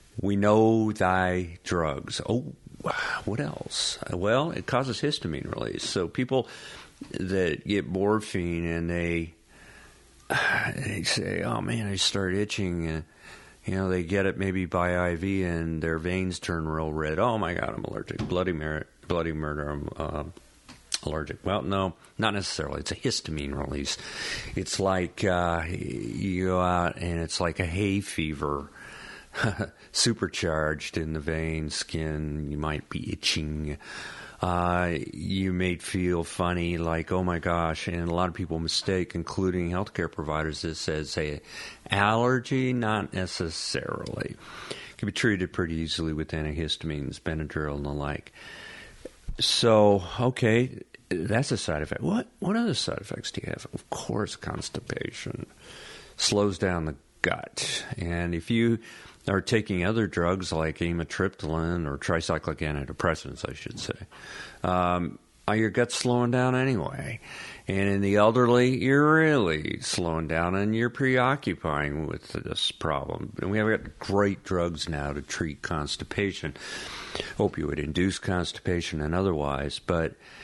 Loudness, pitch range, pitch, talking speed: -28 LUFS, 80-100 Hz, 90 Hz, 145 wpm